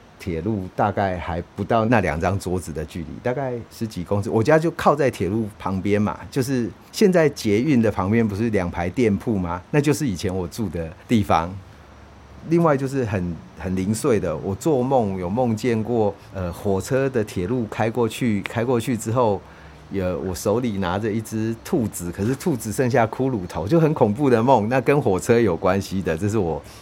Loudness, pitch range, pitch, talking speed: -22 LUFS, 90-120 Hz, 105 Hz, 275 characters per minute